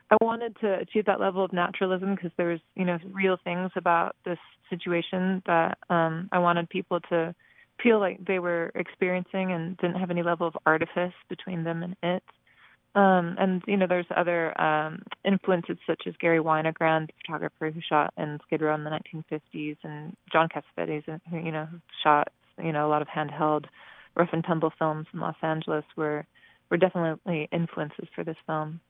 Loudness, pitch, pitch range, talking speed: -28 LUFS, 170 Hz, 160-185 Hz, 185 wpm